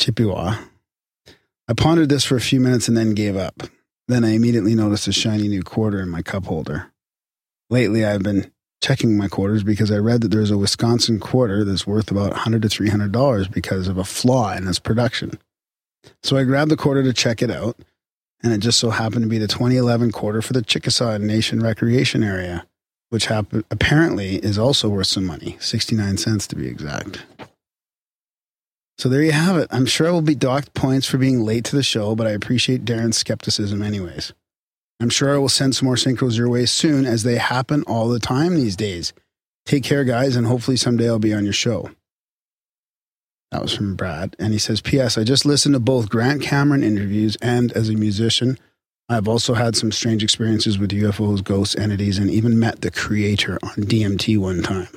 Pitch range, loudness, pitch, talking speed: 105-125 Hz, -19 LUFS, 115 Hz, 200 wpm